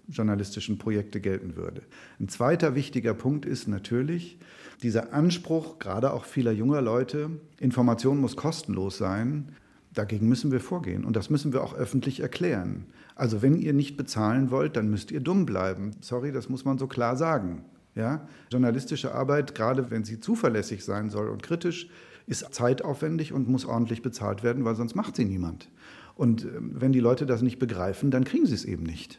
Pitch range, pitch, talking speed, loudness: 110-140 Hz, 125 Hz, 175 wpm, -28 LUFS